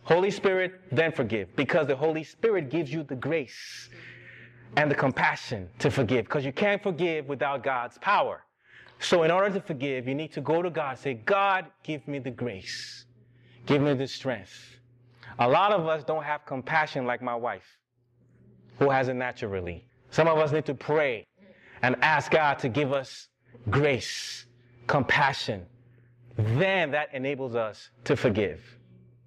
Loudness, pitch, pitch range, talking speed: -27 LUFS, 135 Hz, 120-155 Hz, 160 wpm